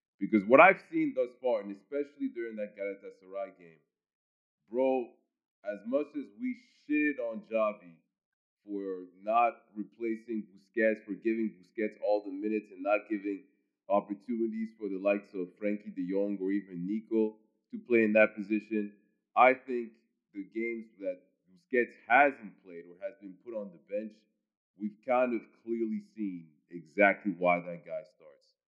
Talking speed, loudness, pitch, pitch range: 155 wpm, -31 LUFS, 110 Hz, 100-125 Hz